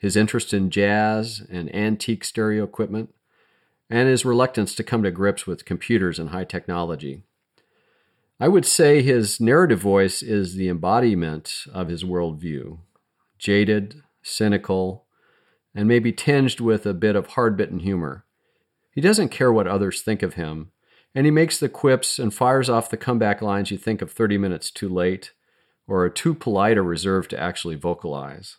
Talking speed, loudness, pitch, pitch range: 165 wpm, -21 LUFS, 100 Hz, 90-115 Hz